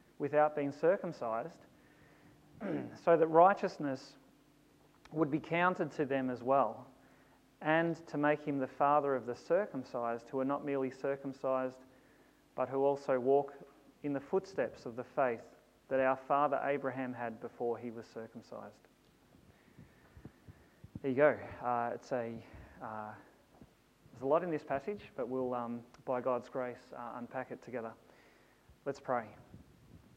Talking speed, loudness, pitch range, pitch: 140 wpm, -35 LUFS, 120-145 Hz, 135 Hz